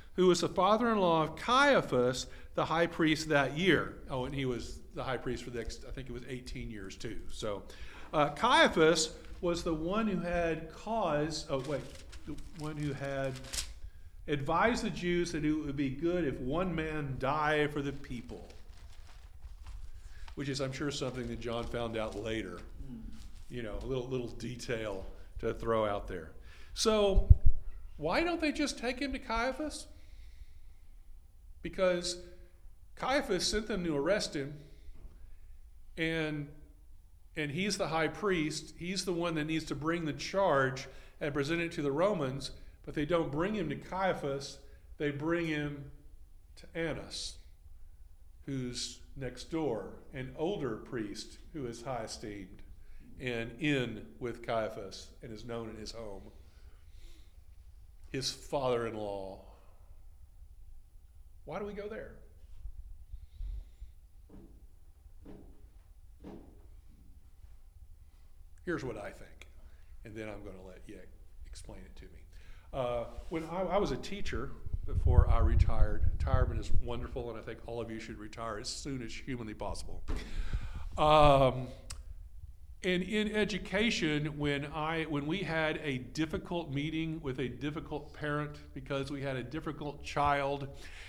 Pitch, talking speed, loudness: 125 Hz, 140 wpm, -34 LUFS